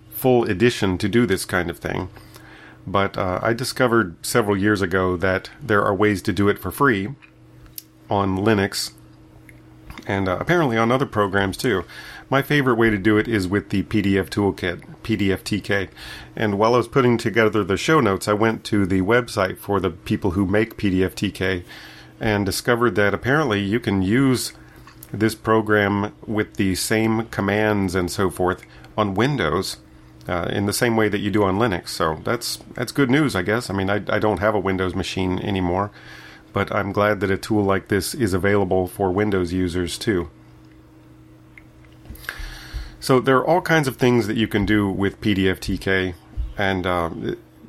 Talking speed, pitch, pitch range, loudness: 175 wpm, 100 Hz, 95-110 Hz, -21 LUFS